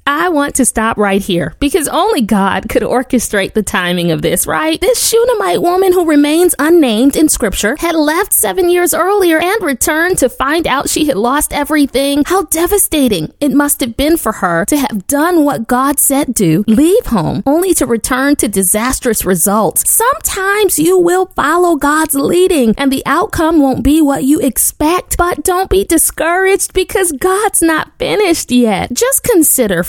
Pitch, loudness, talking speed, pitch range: 295 Hz, -11 LUFS, 170 wpm, 250-355 Hz